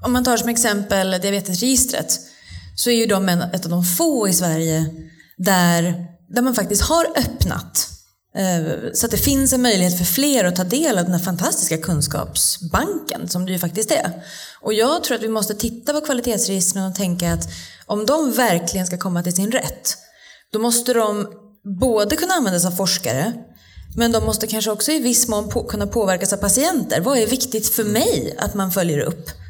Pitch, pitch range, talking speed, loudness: 210 Hz, 180-240 Hz, 190 wpm, -19 LUFS